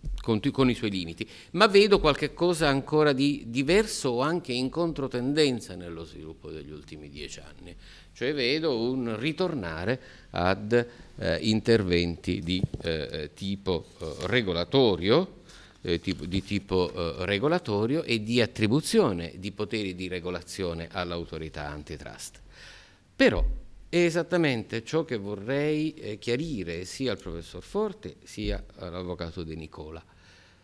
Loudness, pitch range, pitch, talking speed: -27 LUFS, 85-135 Hz, 105 Hz, 125 wpm